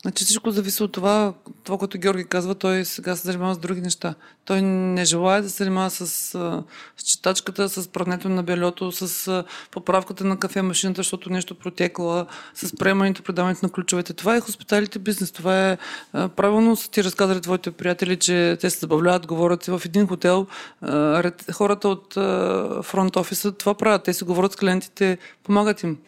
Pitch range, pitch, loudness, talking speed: 180-195 Hz, 185 Hz, -22 LUFS, 175 wpm